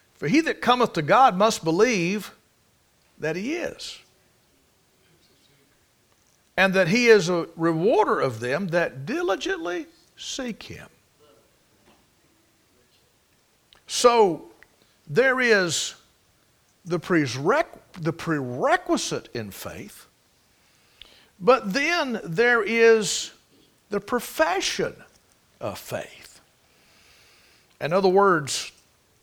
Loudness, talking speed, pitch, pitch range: -22 LUFS, 85 wpm, 205 Hz, 165-245 Hz